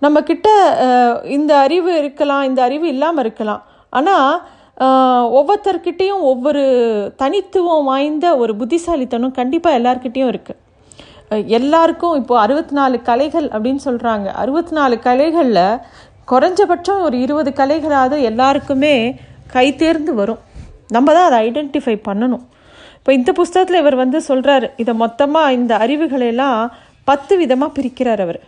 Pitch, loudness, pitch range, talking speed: 275 Hz, -14 LUFS, 250-320 Hz, 115 wpm